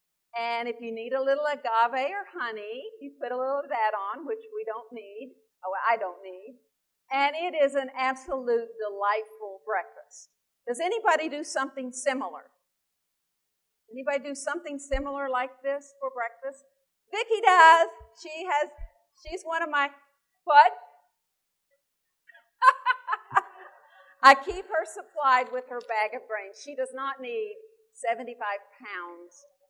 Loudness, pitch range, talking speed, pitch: -26 LUFS, 230-300 Hz, 135 wpm, 270 Hz